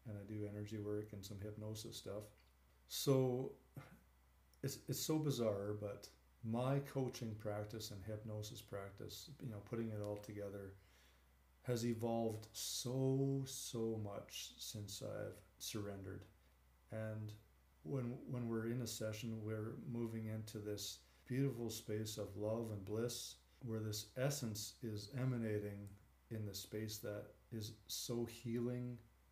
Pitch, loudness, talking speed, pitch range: 110 Hz, -45 LUFS, 130 wpm, 105-120 Hz